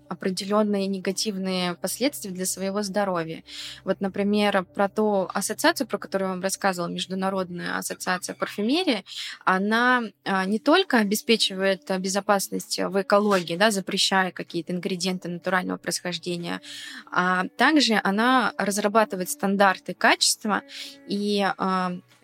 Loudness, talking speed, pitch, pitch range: -24 LUFS, 105 wpm, 195 Hz, 185-210 Hz